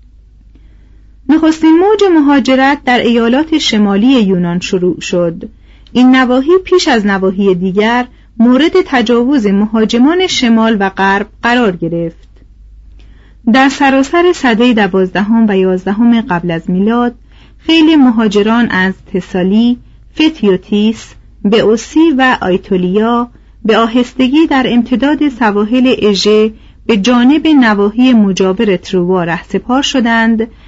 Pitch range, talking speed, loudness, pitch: 190-260 Hz, 105 wpm, -10 LUFS, 225 Hz